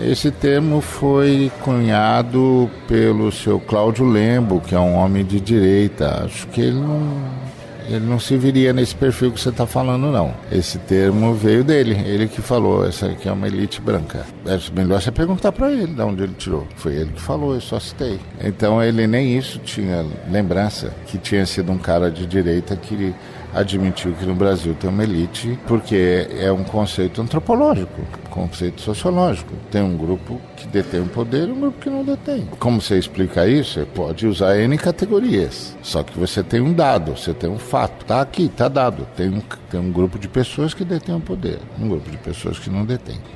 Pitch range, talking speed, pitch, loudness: 95-130 Hz, 195 wpm, 110 Hz, -19 LUFS